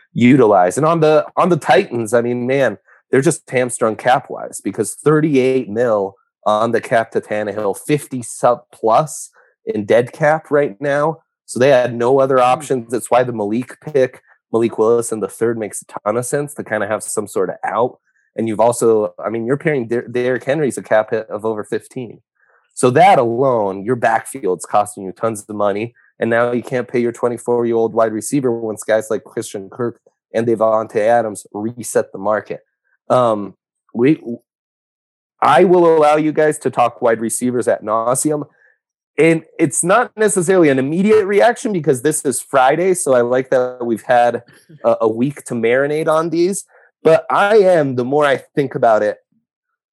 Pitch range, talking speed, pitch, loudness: 115-150 Hz, 185 wpm, 125 Hz, -16 LUFS